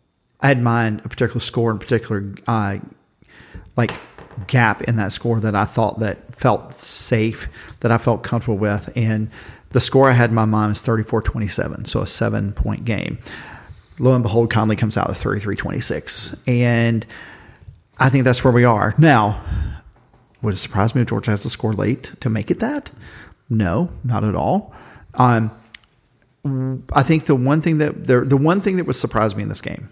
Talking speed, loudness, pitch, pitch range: 185 wpm, -18 LUFS, 115 Hz, 105-125 Hz